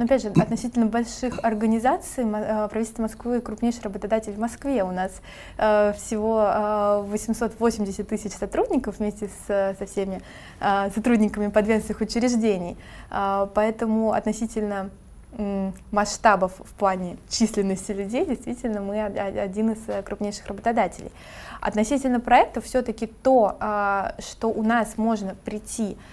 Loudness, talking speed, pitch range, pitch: -24 LUFS, 105 wpm, 205-230 Hz, 215 Hz